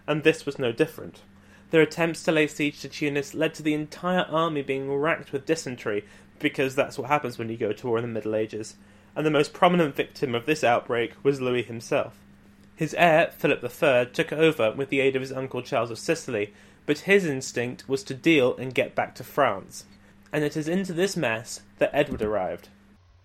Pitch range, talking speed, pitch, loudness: 110-155 Hz, 205 wpm, 135 Hz, -25 LUFS